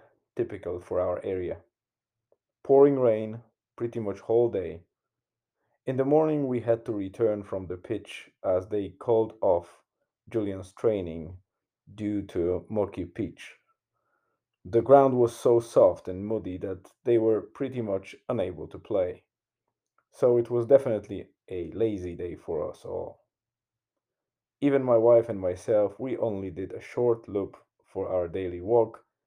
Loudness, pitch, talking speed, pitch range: -27 LUFS, 110 Hz, 145 wpm, 95-120 Hz